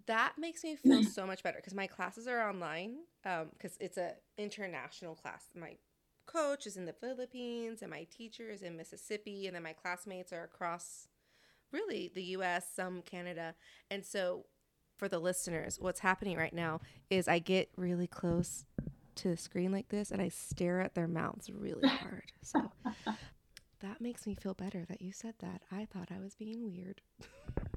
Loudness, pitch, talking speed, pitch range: -39 LUFS, 185 Hz, 180 wpm, 175-210 Hz